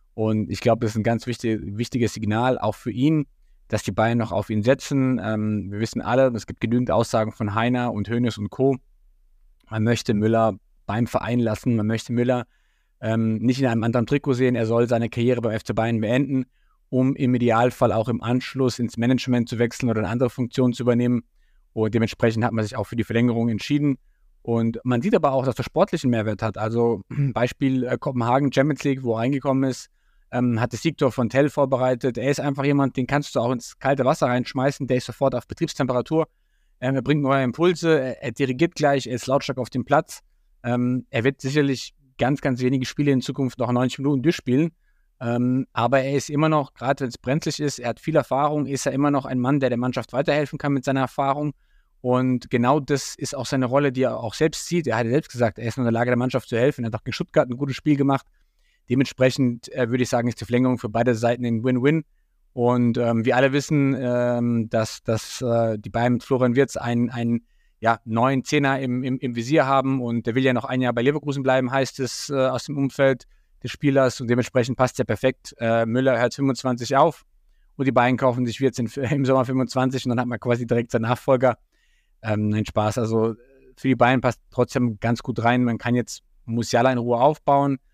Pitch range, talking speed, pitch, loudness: 115-135 Hz, 220 wpm, 125 Hz, -22 LUFS